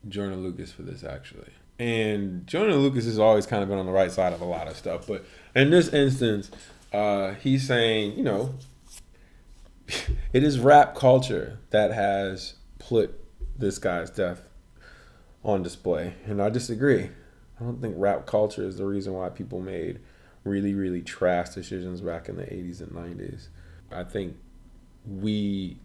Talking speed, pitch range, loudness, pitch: 160 wpm, 90-110 Hz, -25 LUFS, 100 Hz